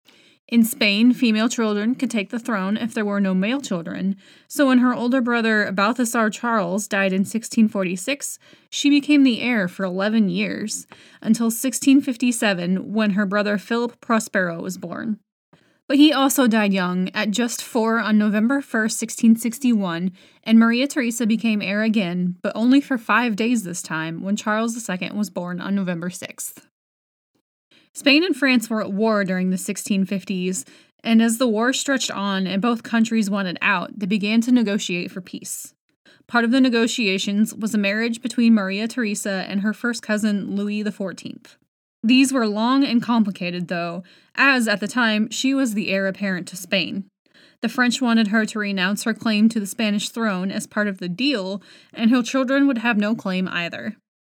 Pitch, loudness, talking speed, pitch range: 220 Hz, -20 LUFS, 175 wpm, 200-240 Hz